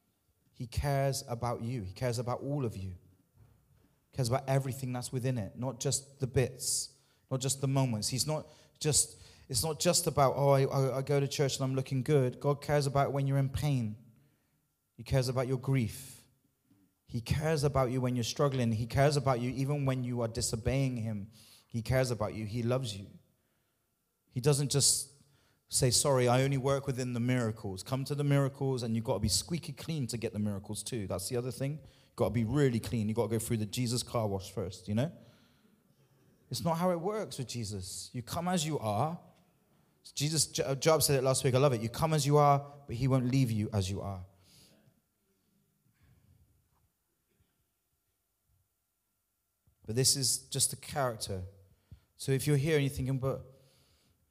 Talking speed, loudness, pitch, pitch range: 195 wpm, -32 LUFS, 130 Hz, 115-140 Hz